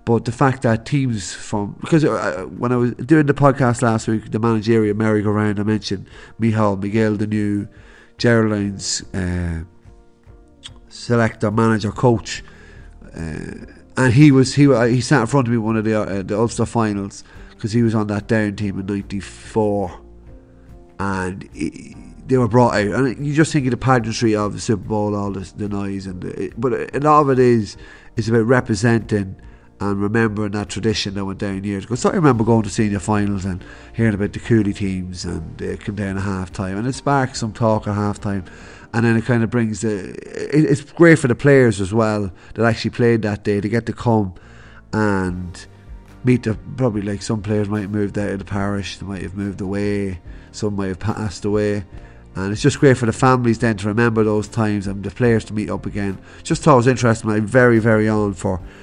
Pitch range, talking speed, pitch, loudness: 100-115 Hz, 205 wpm, 110 Hz, -19 LUFS